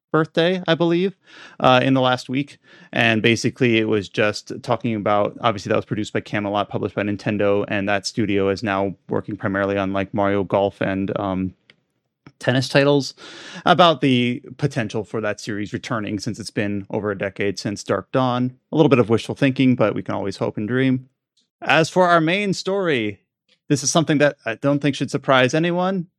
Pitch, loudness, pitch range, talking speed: 120 Hz, -20 LUFS, 105-145 Hz, 190 wpm